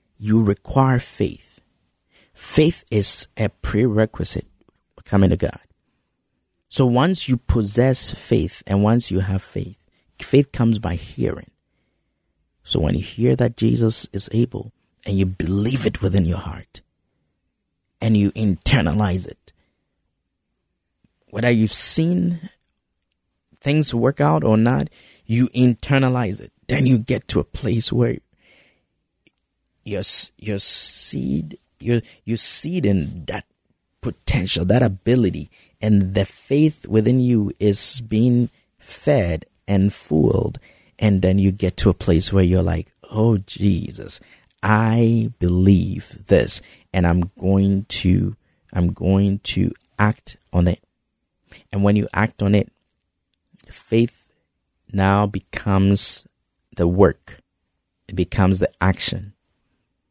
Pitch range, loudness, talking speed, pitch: 90-115 Hz, -19 LUFS, 120 wpm, 100 Hz